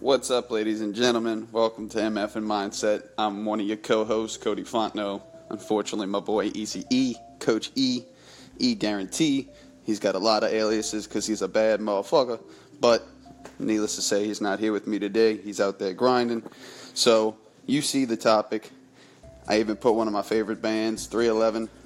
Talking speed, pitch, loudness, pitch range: 180 wpm, 110 Hz, -25 LUFS, 105-115 Hz